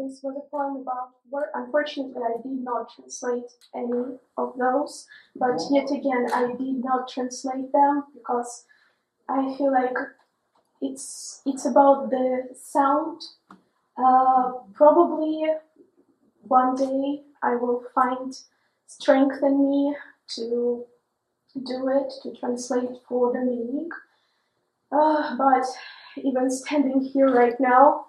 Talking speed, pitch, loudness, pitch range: 120 wpm, 265 Hz, -24 LUFS, 255-285 Hz